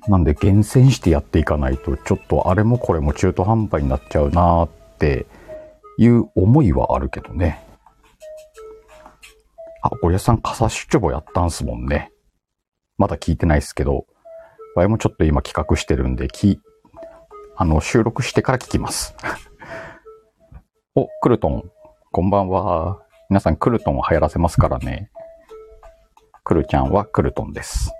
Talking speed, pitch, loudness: 310 characters per minute, 100 Hz, -19 LUFS